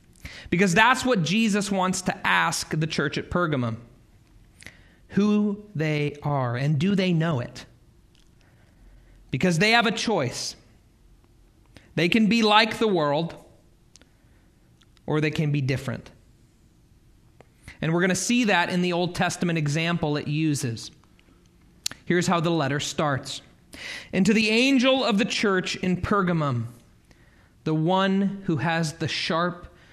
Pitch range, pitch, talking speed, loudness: 125-190 Hz, 160 Hz, 135 wpm, -23 LUFS